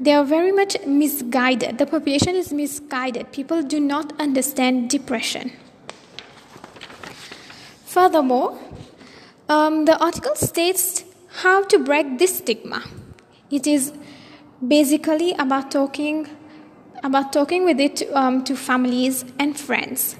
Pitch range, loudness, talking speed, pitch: 265-315 Hz, -20 LUFS, 115 wpm, 290 Hz